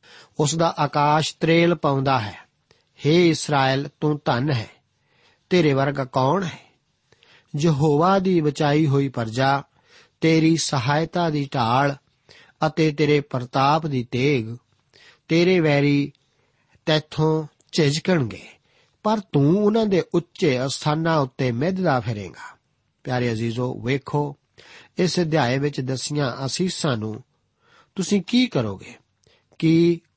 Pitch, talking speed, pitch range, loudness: 145 Hz, 110 wpm, 130-160 Hz, -21 LUFS